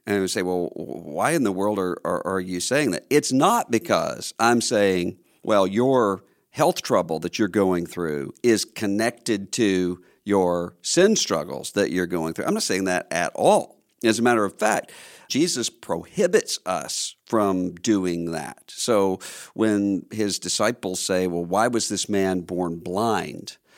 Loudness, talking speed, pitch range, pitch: -23 LUFS, 165 wpm, 90-110 Hz, 95 Hz